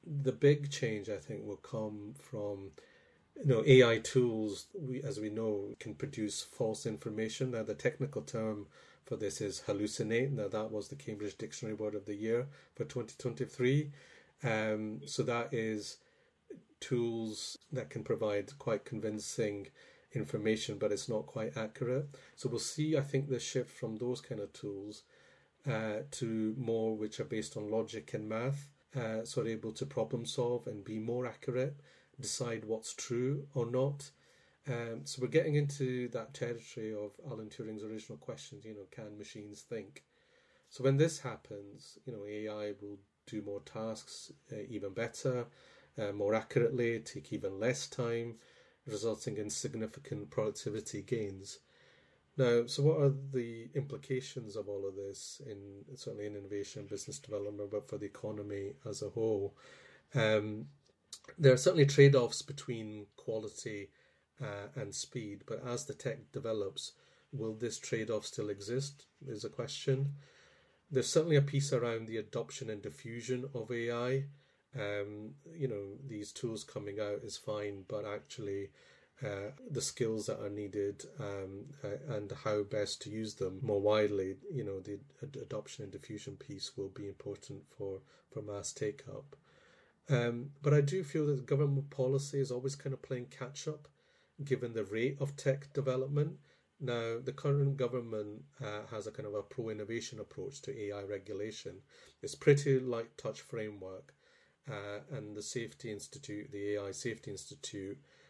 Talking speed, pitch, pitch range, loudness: 160 wpm, 115 Hz, 105-135 Hz, -37 LUFS